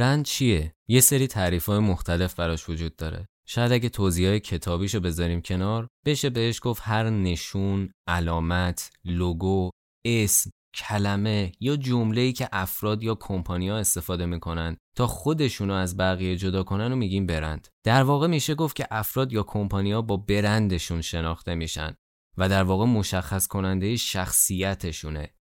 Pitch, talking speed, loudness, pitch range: 95 Hz, 145 wpm, -25 LUFS, 90-115 Hz